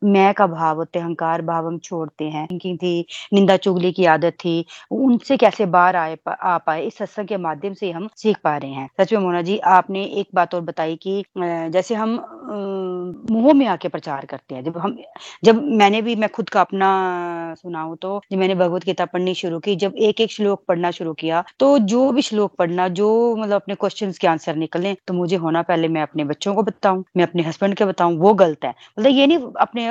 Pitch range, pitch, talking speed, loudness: 170-210 Hz, 185 Hz, 215 wpm, -19 LUFS